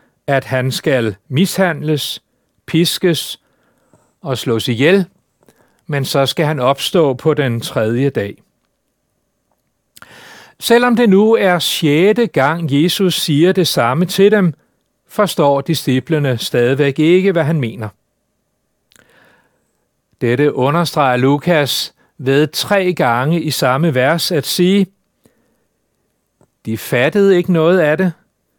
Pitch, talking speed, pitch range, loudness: 155 Hz, 110 wpm, 135-180 Hz, -14 LUFS